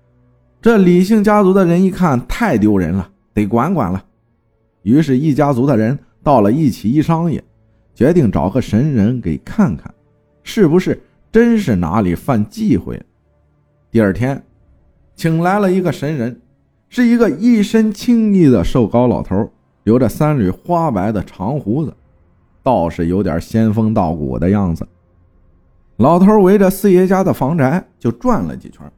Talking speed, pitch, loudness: 225 characters per minute, 120 Hz, -14 LUFS